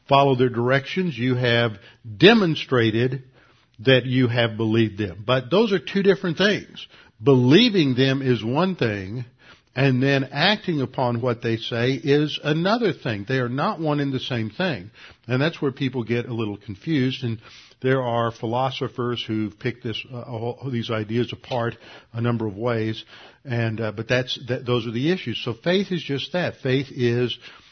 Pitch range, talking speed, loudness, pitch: 115-140 Hz, 175 wpm, -22 LUFS, 125 Hz